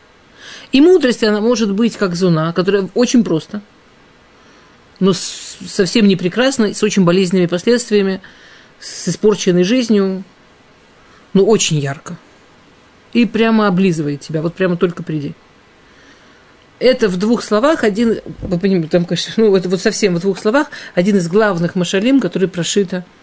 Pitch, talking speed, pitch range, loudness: 195 Hz, 135 wpm, 180-220 Hz, -15 LUFS